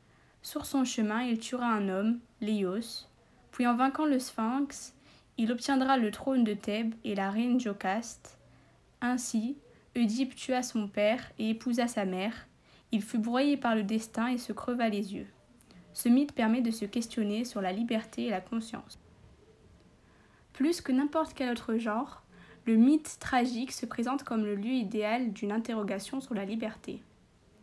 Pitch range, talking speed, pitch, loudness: 220-255 Hz, 165 wpm, 230 Hz, -31 LUFS